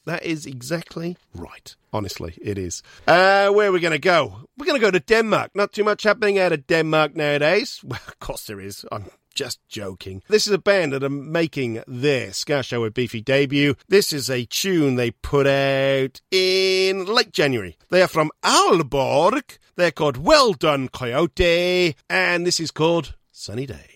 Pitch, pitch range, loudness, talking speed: 155 Hz, 135-185 Hz, -19 LUFS, 185 wpm